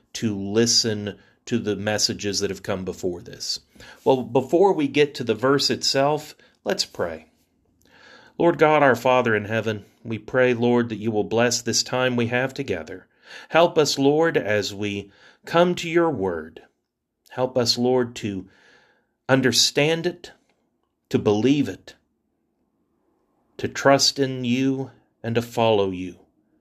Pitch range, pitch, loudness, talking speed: 110-135 Hz, 120 Hz, -21 LUFS, 145 wpm